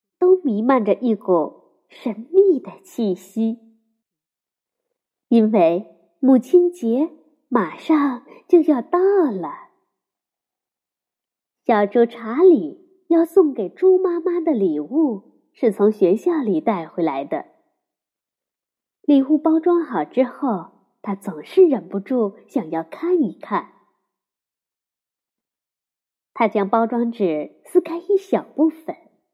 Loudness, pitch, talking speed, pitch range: -19 LUFS, 260 Hz, 150 characters per minute, 210-340 Hz